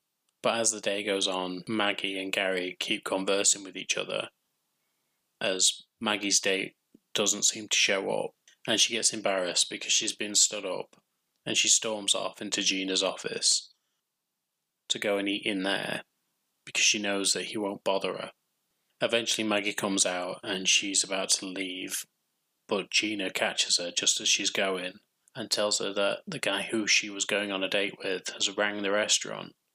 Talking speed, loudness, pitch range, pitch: 175 wpm, -27 LUFS, 95-105 Hz, 100 Hz